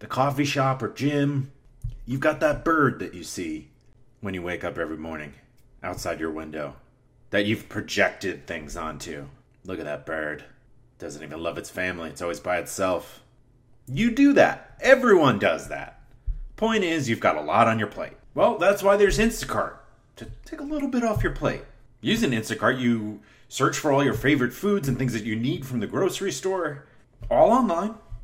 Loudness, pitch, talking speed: -24 LUFS, 130 Hz, 185 wpm